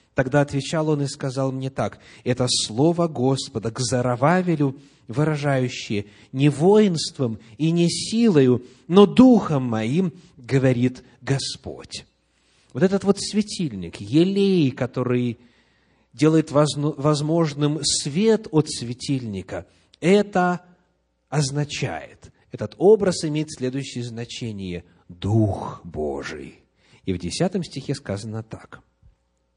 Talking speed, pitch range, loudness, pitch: 100 wpm, 120-160 Hz, -22 LUFS, 135 Hz